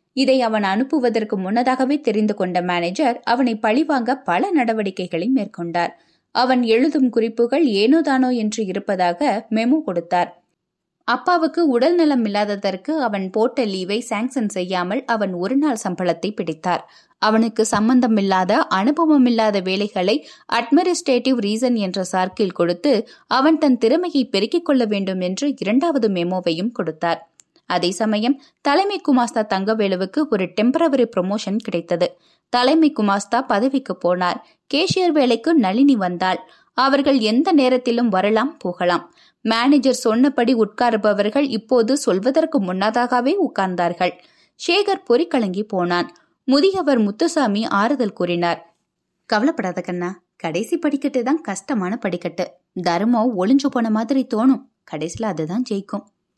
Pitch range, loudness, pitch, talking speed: 185-265 Hz, -19 LUFS, 225 Hz, 110 wpm